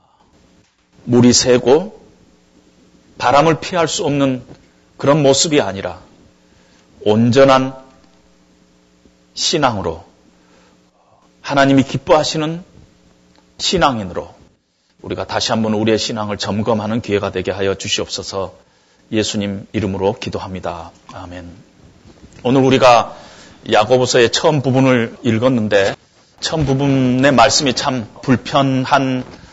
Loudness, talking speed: -15 LUFS, 235 characters per minute